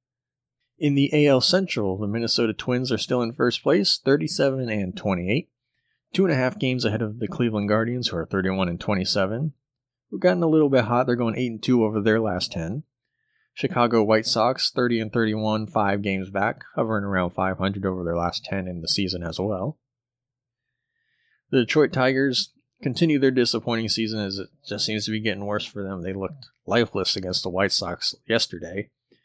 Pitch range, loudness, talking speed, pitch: 100-130 Hz, -23 LUFS, 185 wpm, 115 Hz